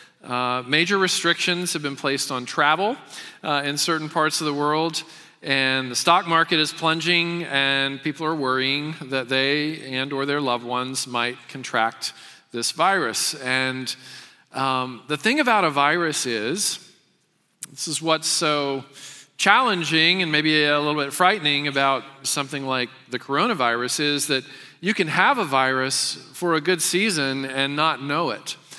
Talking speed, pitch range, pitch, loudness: 155 wpm, 130-165 Hz, 145 Hz, -21 LUFS